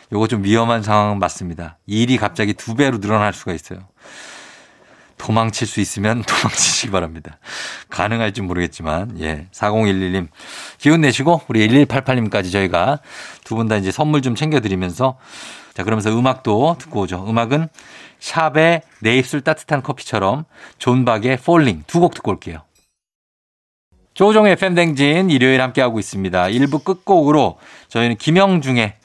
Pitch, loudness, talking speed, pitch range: 115 Hz, -17 LUFS, 315 characters per minute, 100-145 Hz